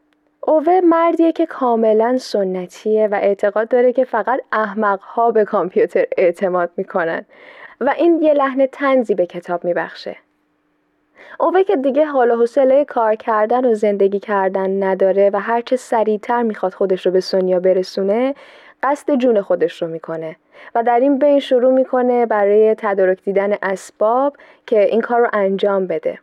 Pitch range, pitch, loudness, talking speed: 195-265 Hz, 220 Hz, -16 LUFS, 150 wpm